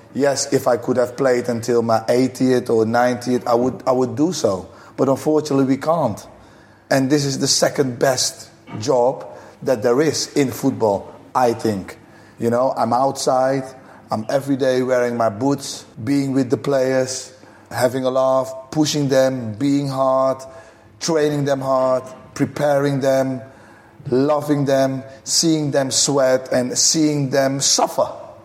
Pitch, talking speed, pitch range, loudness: 130 Hz, 150 wpm, 125-140 Hz, -18 LUFS